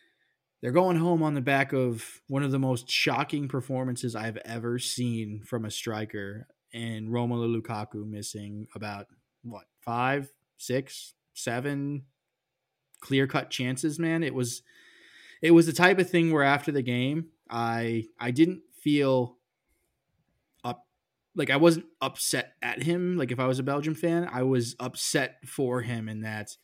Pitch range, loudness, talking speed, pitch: 115-145 Hz, -28 LUFS, 155 wpm, 130 Hz